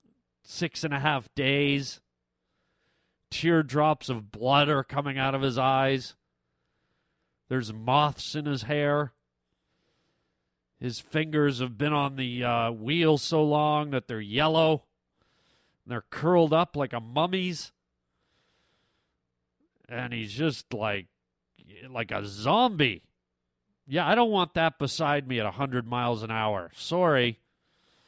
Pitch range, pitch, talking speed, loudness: 110-150 Hz, 130 Hz, 125 wpm, -27 LUFS